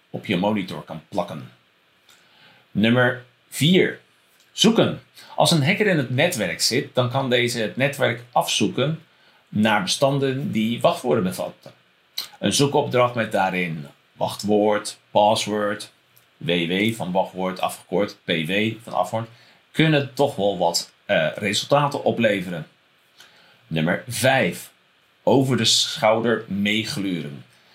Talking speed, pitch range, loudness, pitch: 110 wpm, 95-125 Hz, -21 LUFS, 110 Hz